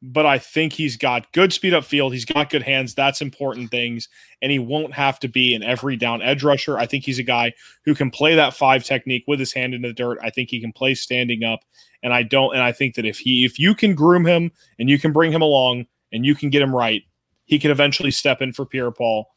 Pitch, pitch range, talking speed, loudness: 135 Hz, 125-145 Hz, 265 wpm, -19 LUFS